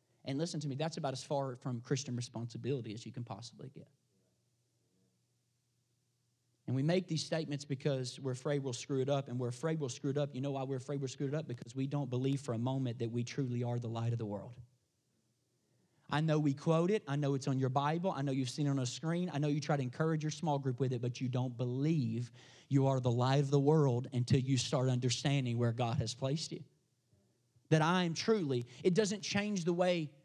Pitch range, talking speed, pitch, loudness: 125-145 Hz, 235 wpm, 135 Hz, -35 LUFS